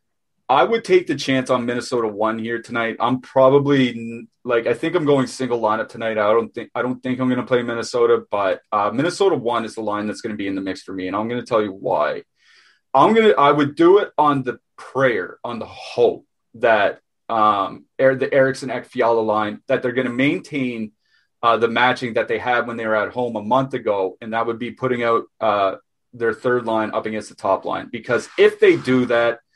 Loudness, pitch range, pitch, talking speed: -19 LUFS, 115-130 Hz, 120 Hz, 230 wpm